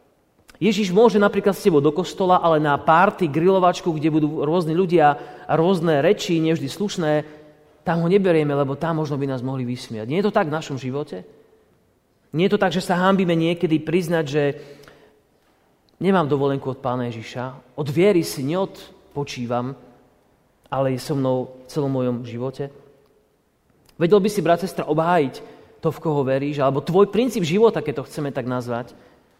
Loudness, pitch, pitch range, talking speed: -21 LUFS, 155 Hz, 135-180 Hz, 170 wpm